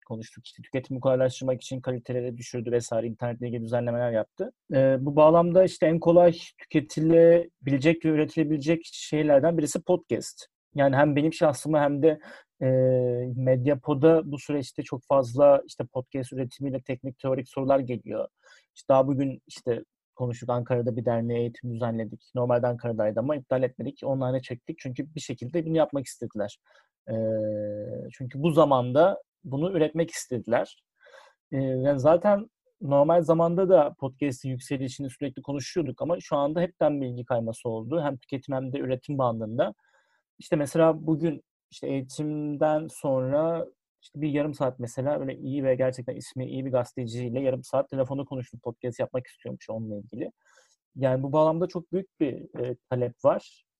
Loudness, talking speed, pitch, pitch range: -26 LUFS, 145 wpm, 135 Hz, 125-155 Hz